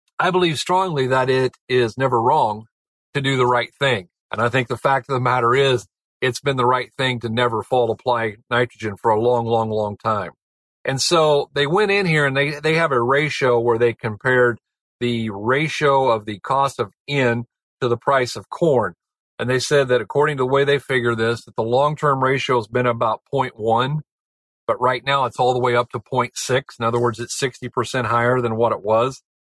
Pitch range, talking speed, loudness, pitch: 120-140 Hz, 215 wpm, -19 LUFS, 125 Hz